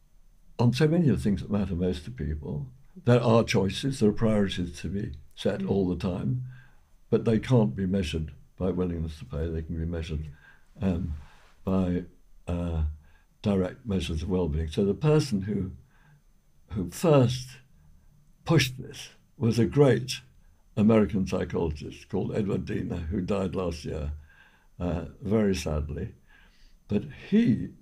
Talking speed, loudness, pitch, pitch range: 150 wpm, -28 LUFS, 95 Hz, 80-115 Hz